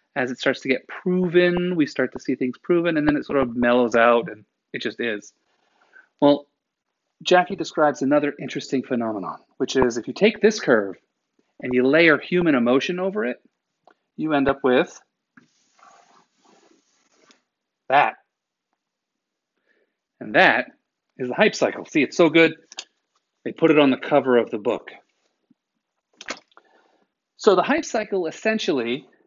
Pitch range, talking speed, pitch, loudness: 130-180 Hz, 150 wpm, 150 Hz, -21 LUFS